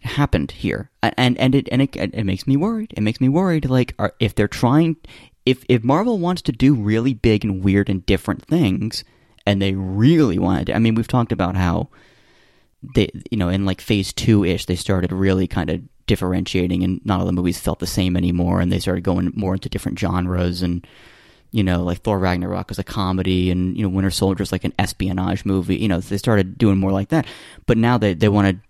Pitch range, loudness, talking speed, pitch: 95-120 Hz, -19 LUFS, 225 wpm, 100 Hz